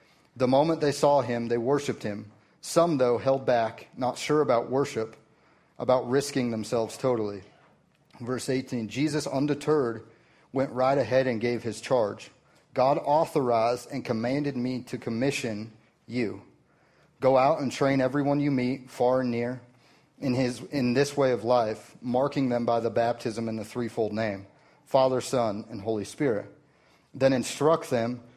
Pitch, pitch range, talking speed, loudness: 125 Hz, 115-135 Hz, 155 wpm, -27 LUFS